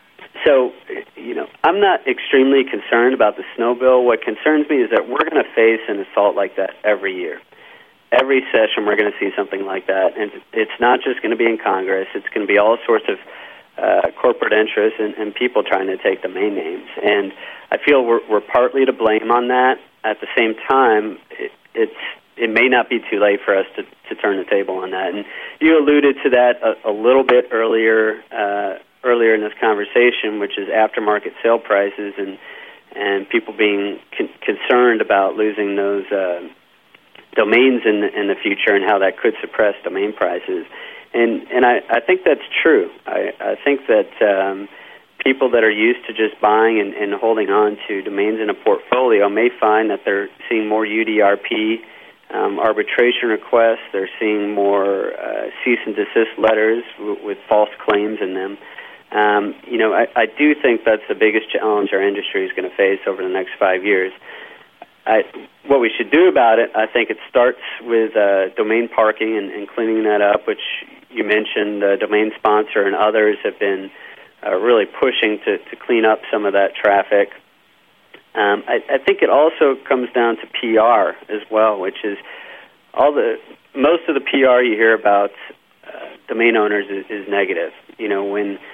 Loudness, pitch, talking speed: -17 LUFS, 115 Hz, 195 wpm